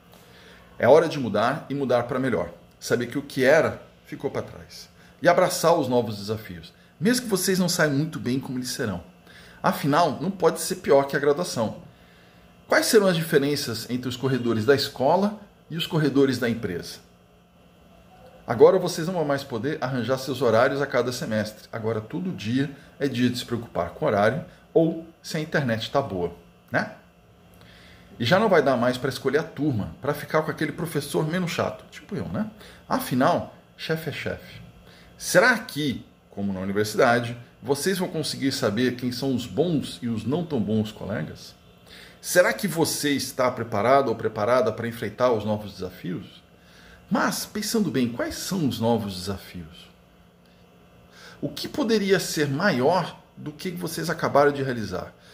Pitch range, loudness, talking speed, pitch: 110-160 Hz, -24 LUFS, 170 wpm, 130 Hz